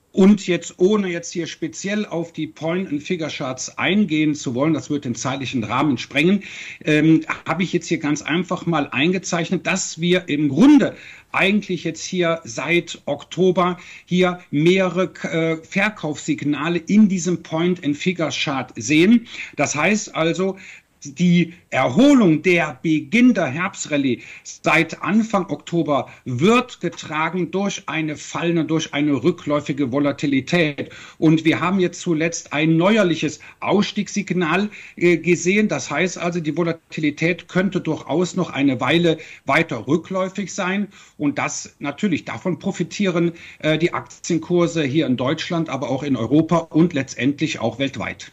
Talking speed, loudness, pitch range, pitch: 130 wpm, -20 LUFS, 150-180 Hz, 165 Hz